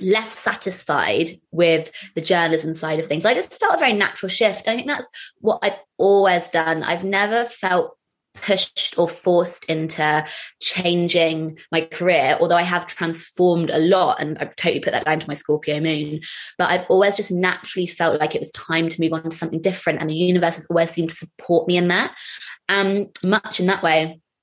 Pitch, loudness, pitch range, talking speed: 170 Hz, -20 LUFS, 160-190 Hz, 195 wpm